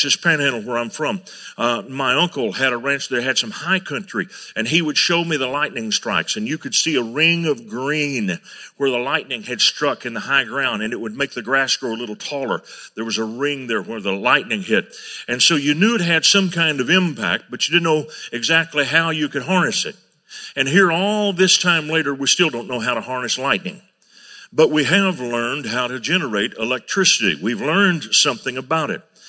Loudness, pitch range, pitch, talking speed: -18 LUFS, 125-175 Hz, 150 Hz, 220 wpm